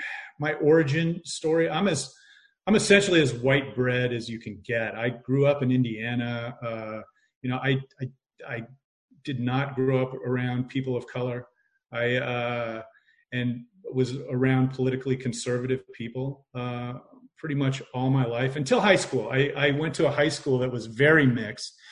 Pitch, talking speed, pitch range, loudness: 130 Hz, 165 wpm, 120-145 Hz, -26 LUFS